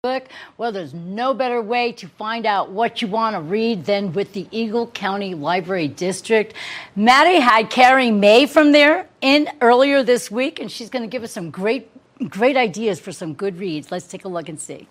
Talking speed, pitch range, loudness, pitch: 200 wpm, 190-250 Hz, -18 LUFS, 225 Hz